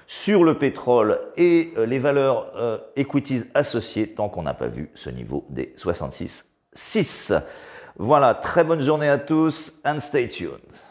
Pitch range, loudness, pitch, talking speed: 125-165 Hz, -22 LUFS, 145 Hz, 150 wpm